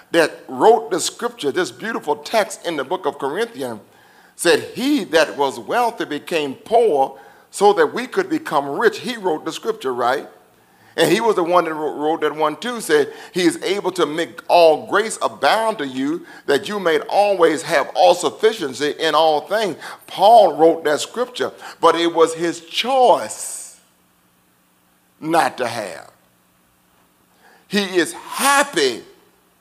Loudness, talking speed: -18 LUFS, 155 wpm